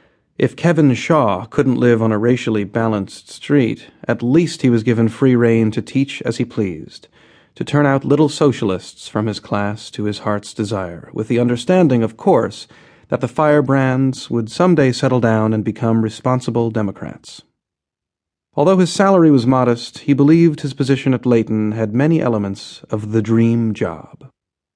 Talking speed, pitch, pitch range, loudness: 165 wpm, 120 Hz, 110-140 Hz, -16 LUFS